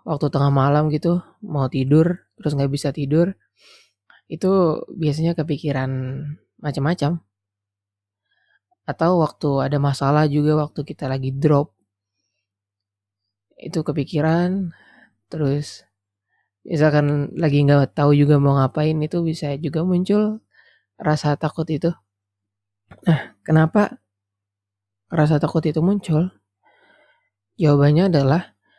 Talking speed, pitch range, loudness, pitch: 100 wpm, 130-160 Hz, -20 LUFS, 150 Hz